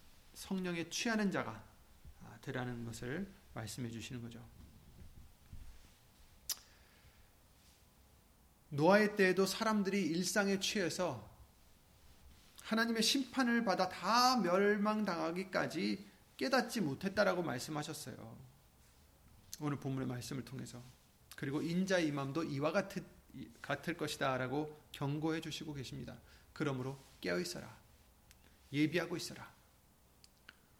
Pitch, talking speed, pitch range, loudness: 145 Hz, 240 characters per minute, 115-185 Hz, -37 LUFS